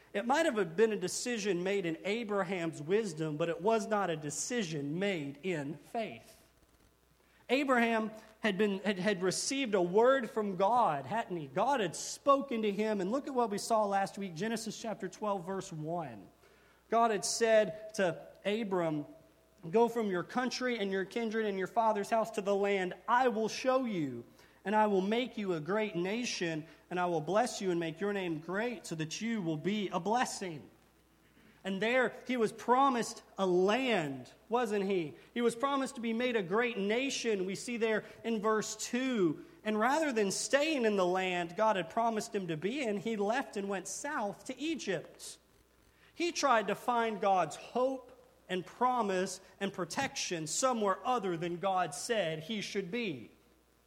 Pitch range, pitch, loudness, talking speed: 185-230 Hz, 210 Hz, -33 LUFS, 175 wpm